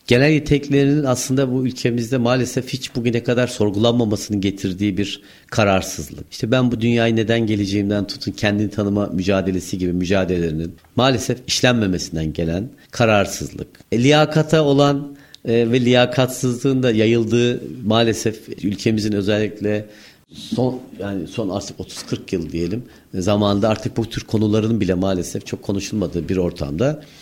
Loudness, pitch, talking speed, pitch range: -19 LUFS, 110 Hz, 125 wpm, 100-125 Hz